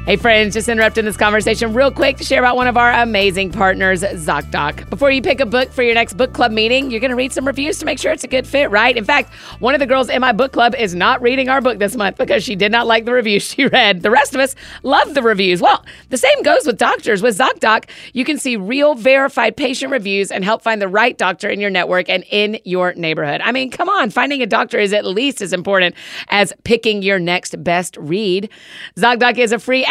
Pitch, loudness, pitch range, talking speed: 235 Hz, -14 LUFS, 200-260 Hz, 255 wpm